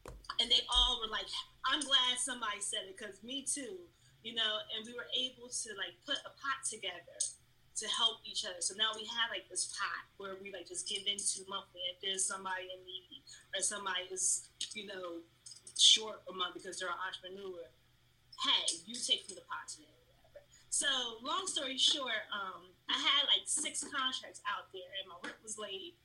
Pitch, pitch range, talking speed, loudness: 210 Hz, 185-250 Hz, 200 wpm, -34 LUFS